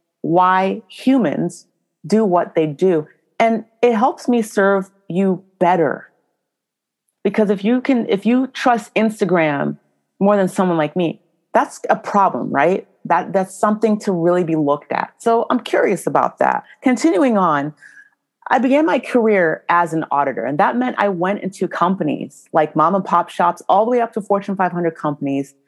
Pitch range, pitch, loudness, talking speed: 170-230 Hz, 195 Hz, -17 LUFS, 170 wpm